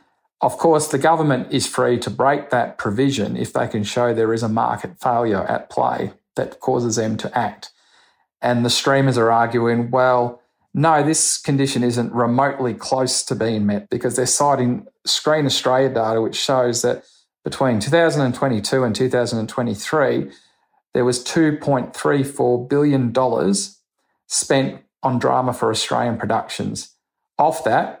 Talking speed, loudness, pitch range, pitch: 145 wpm, -19 LUFS, 120-140 Hz, 125 Hz